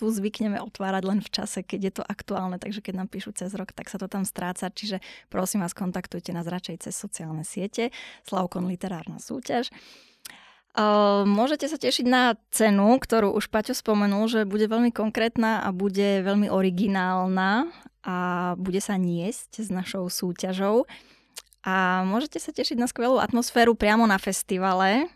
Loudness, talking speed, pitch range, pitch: -25 LUFS, 160 wpm, 190-225 Hz, 205 Hz